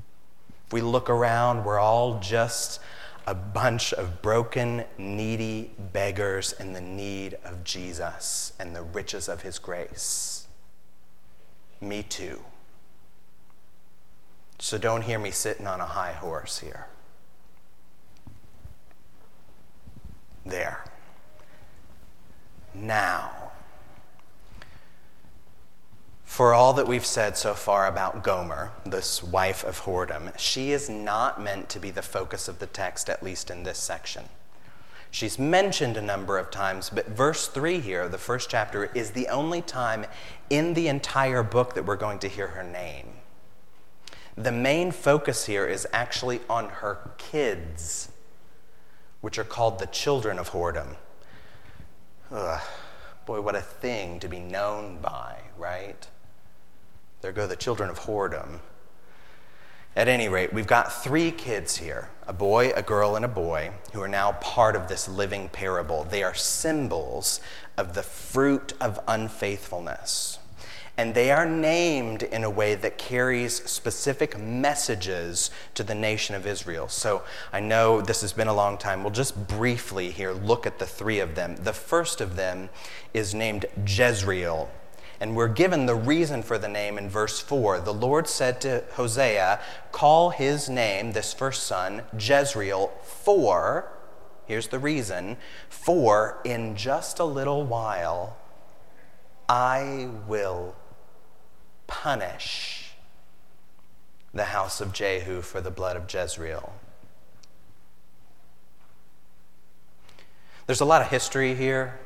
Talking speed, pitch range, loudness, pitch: 135 wpm, 90-120 Hz, -27 LUFS, 105 Hz